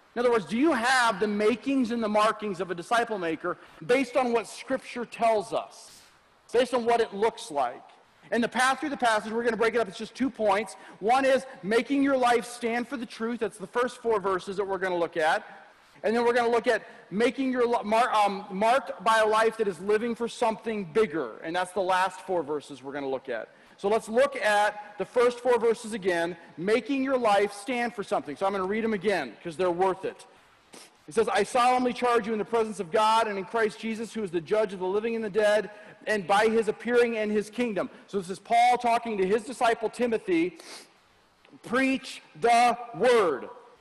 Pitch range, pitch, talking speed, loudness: 200-240 Hz, 225 Hz, 225 wpm, -27 LUFS